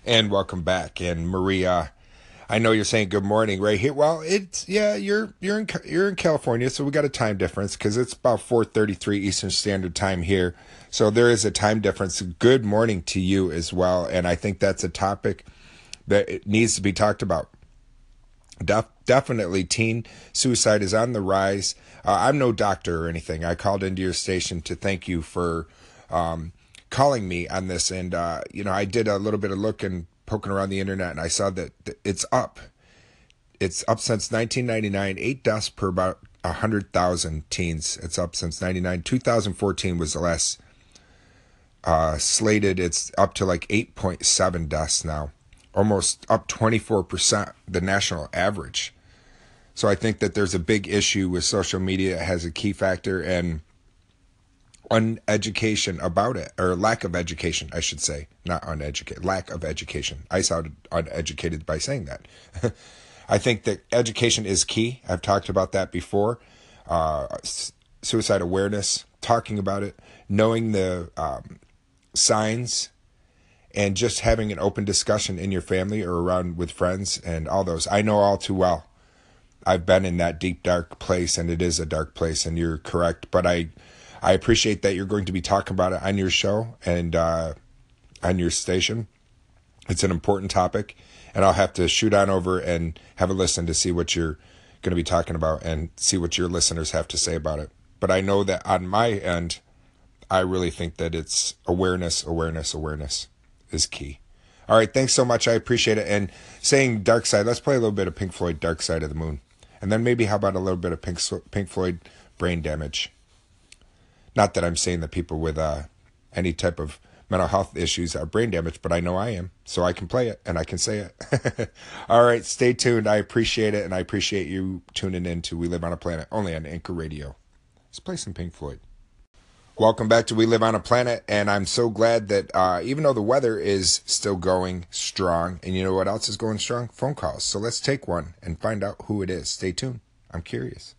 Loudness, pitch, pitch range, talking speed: -24 LUFS, 95 Hz, 85-105 Hz, 200 wpm